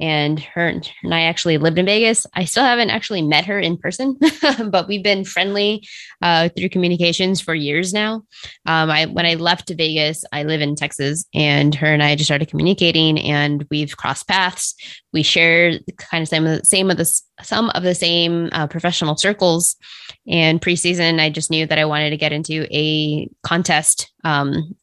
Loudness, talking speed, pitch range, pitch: -17 LUFS, 180 wpm, 155-185 Hz, 165 Hz